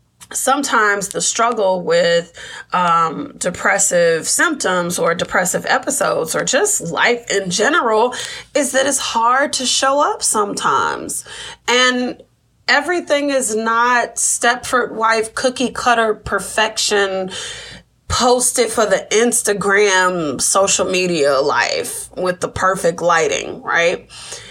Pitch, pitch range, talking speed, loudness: 225 Hz, 190-255 Hz, 110 wpm, -16 LUFS